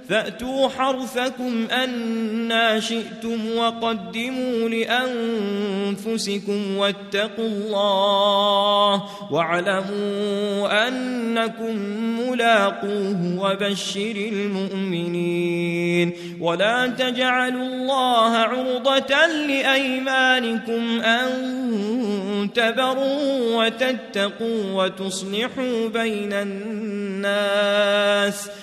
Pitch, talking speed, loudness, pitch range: 225 Hz, 50 wpm, -21 LUFS, 200-245 Hz